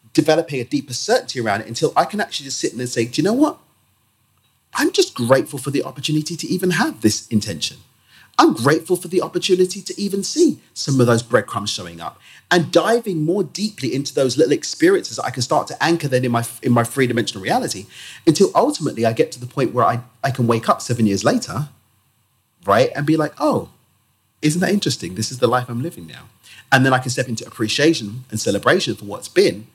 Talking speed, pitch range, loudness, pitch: 220 wpm, 120-170 Hz, -19 LUFS, 135 Hz